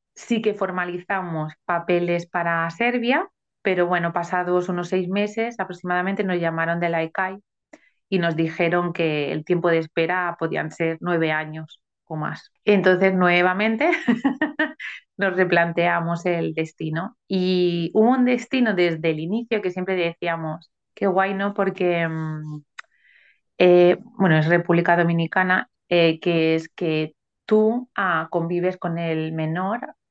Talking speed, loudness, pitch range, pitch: 135 wpm, -22 LUFS, 165-195 Hz, 175 Hz